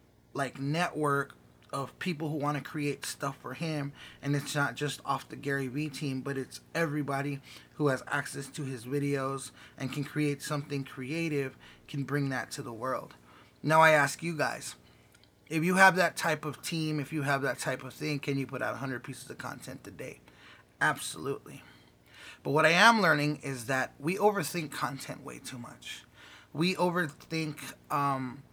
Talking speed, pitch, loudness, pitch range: 180 wpm, 140 Hz, -31 LUFS, 135-155 Hz